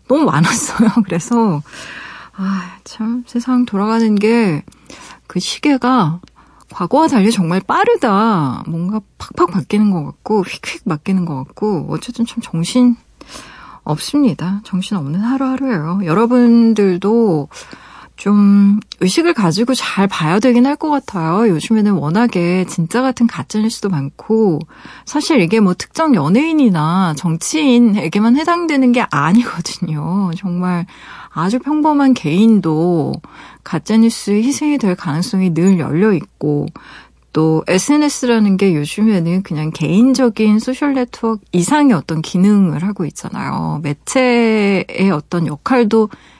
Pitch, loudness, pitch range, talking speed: 205 Hz, -15 LUFS, 175-240 Hz, 275 characters per minute